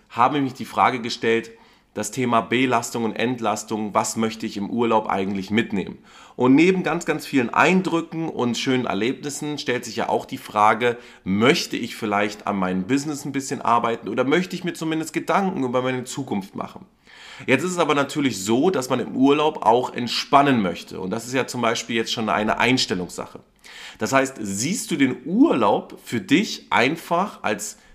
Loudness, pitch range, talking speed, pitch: -22 LUFS, 110-145 Hz, 185 wpm, 125 Hz